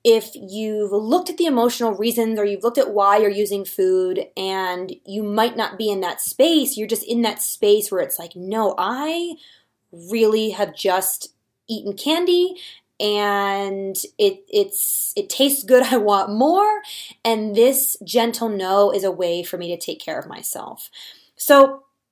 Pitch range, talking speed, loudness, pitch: 200-305 Hz, 170 wpm, -19 LUFS, 225 Hz